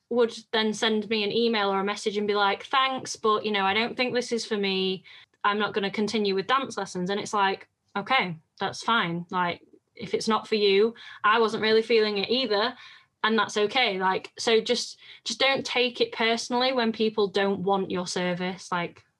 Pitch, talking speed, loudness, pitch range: 215 Hz, 210 wpm, -25 LUFS, 195-235 Hz